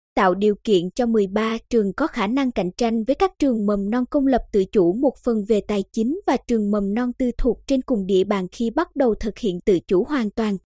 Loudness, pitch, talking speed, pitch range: -21 LUFS, 225 Hz, 245 wpm, 205-255 Hz